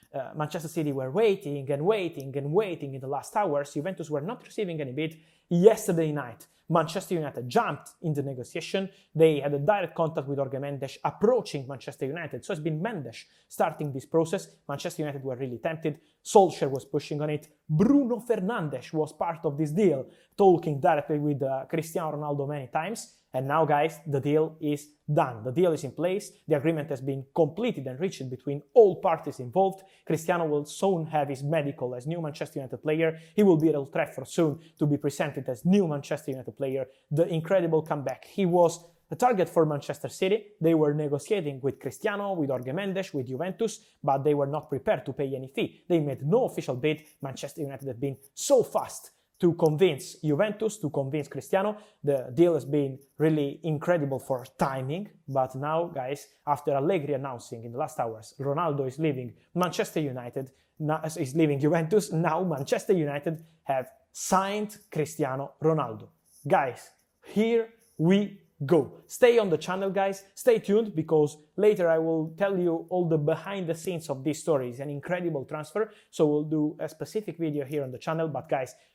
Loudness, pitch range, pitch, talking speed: -28 LUFS, 140-180 Hz, 155 Hz, 180 wpm